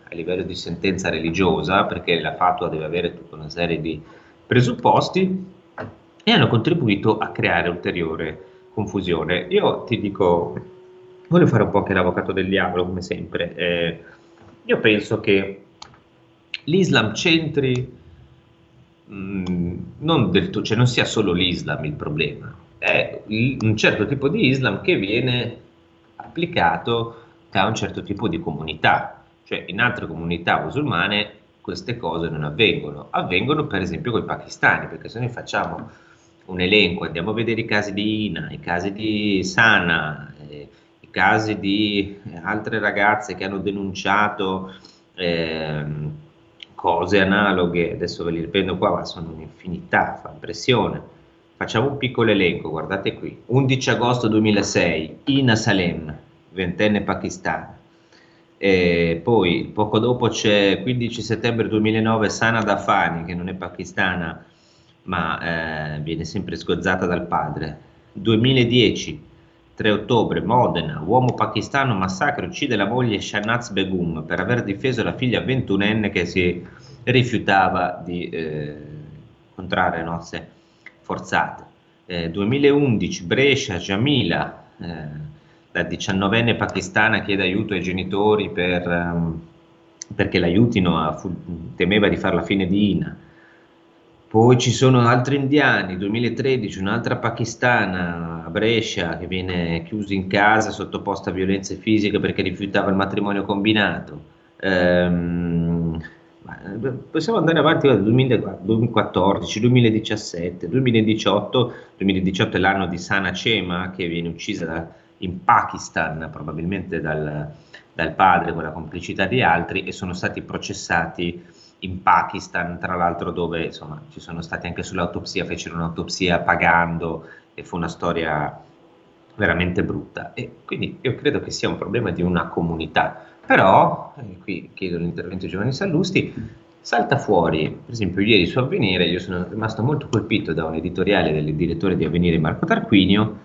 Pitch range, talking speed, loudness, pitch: 85-110 Hz, 135 wpm, -20 LUFS, 95 Hz